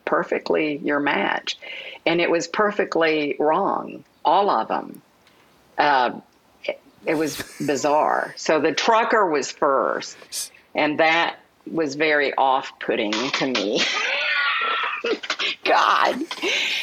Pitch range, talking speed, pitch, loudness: 150-165 Hz, 100 wpm, 160 Hz, -21 LUFS